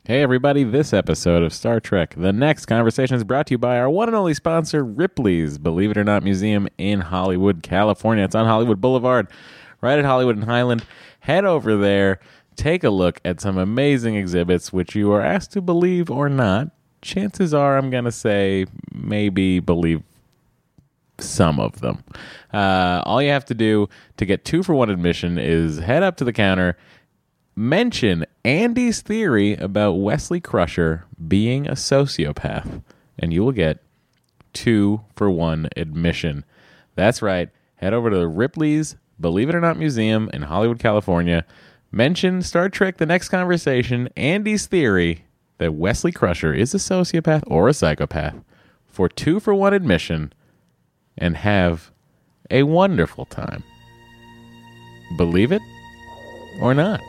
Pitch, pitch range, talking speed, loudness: 115 Hz, 95-145 Hz, 155 wpm, -19 LUFS